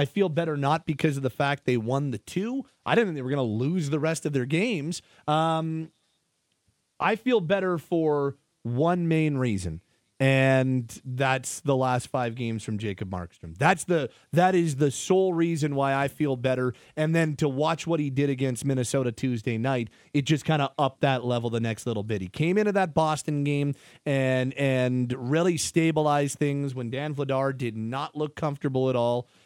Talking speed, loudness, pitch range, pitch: 190 wpm, -26 LUFS, 130-160 Hz, 140 Hz